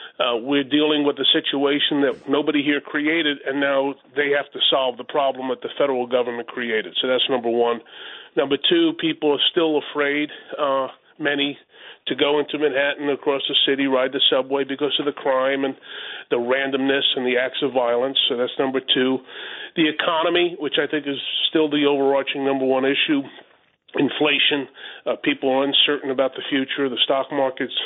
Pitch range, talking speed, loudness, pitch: 130-145 Hz, 180 wpm, -20 LUFS, 140 Hz